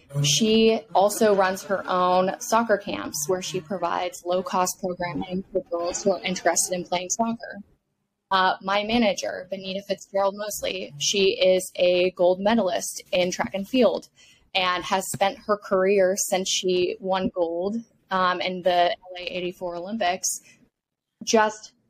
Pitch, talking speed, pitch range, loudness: 190 Hz, 140 wpm, 180-200 Hz, -24 LUFS